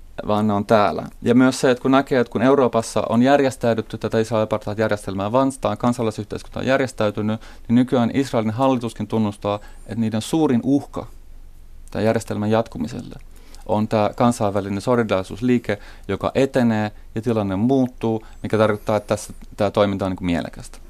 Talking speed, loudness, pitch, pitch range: 150 wpm, -20 LUFS, 110 Hz, 105-120 Hz